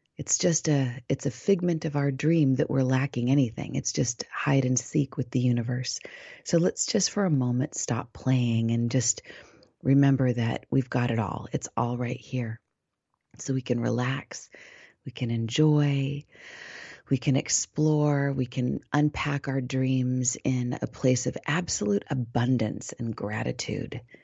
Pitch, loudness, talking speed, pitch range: 130 Hz, -27 LUFS, 160 wpm, 125-145 Hz